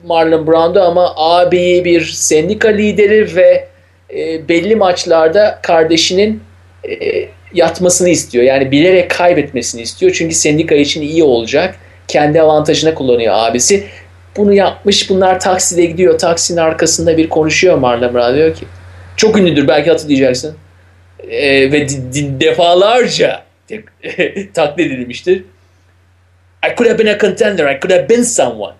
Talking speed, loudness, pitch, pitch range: 130 wpm, -11 LUFS, 165 Hz, 135-185 Hz